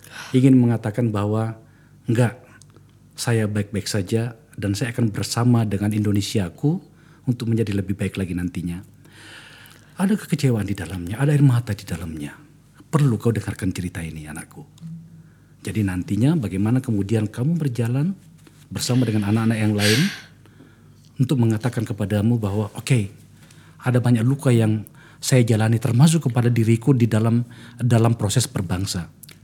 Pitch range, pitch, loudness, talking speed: 105-135 Hz, 115 Hz, -21 LUFS, 130 wpm